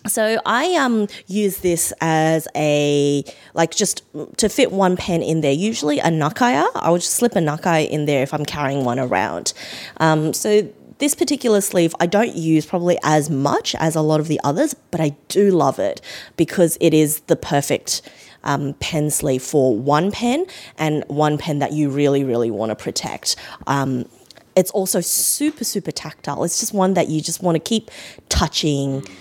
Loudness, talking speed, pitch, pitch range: -19 LUFS, 185 wpm, 160 Hz, 145-195 Hz